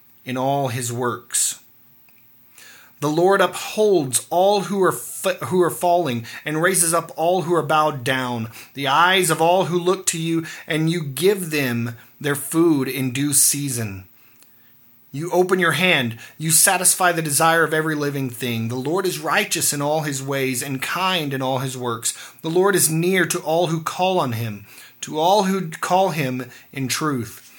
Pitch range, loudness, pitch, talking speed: 130-175 Hz, -19 LUFS, 155 Hz, 180 wpm